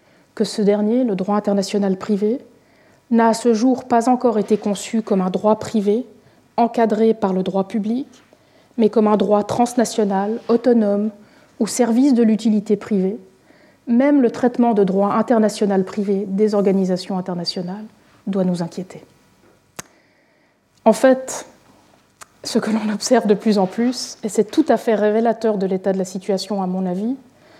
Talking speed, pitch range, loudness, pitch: 160 wpm, 200-235 Hz, -18 LUFS, 215 Hz